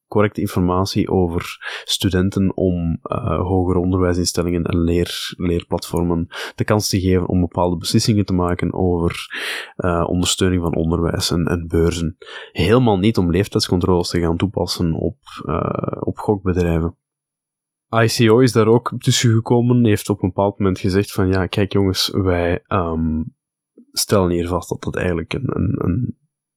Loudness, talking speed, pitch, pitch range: -19 LUFS, 150 wpm, 95 Hz, 85-105 Hz